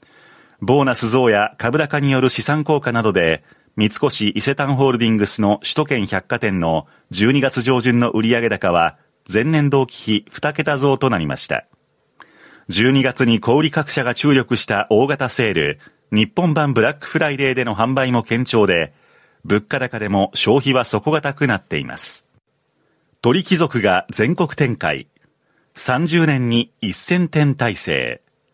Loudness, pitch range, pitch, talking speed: -18 LUFS, 115-145 Hz, 130 Hz, 265 characters per minute